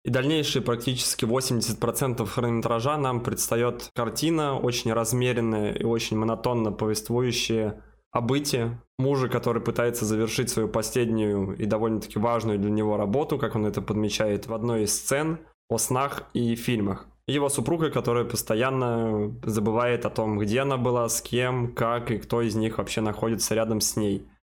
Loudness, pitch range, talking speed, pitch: -26 LUFS, 110-125 Hz, 150 wpm, 115 Hz